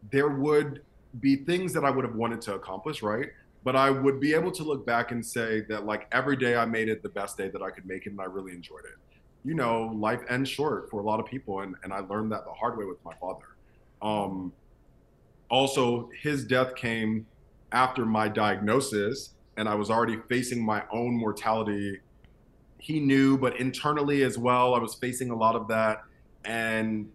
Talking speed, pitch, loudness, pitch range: 205 wpm, 115 Hz, -28 LUFS, 105-130 Hz